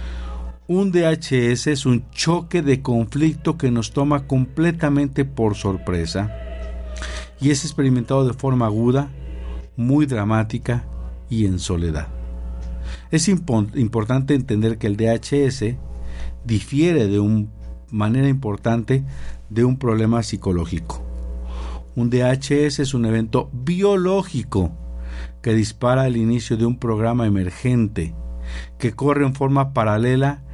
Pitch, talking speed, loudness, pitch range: 115 Hz, 115 wpm, -20 LUFS, 85-135 Hz